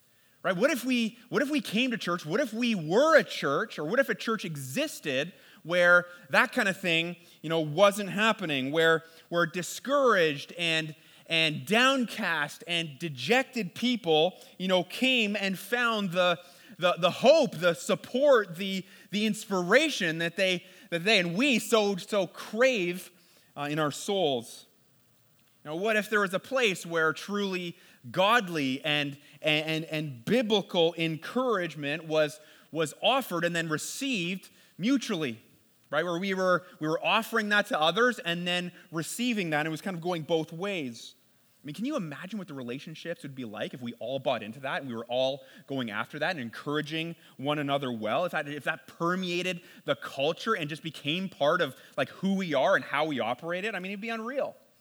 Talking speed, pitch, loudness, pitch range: 180 wpm, 175 Hz, -28 LUFS, 155-210 Hz